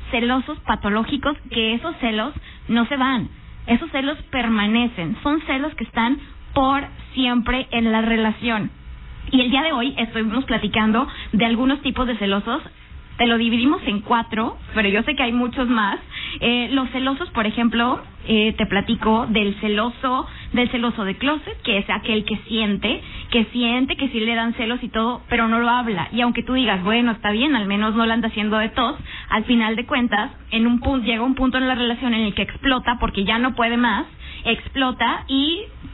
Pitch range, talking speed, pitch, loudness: 220-255 Hz, 190 wpm, 235 Hz, -20 LUFS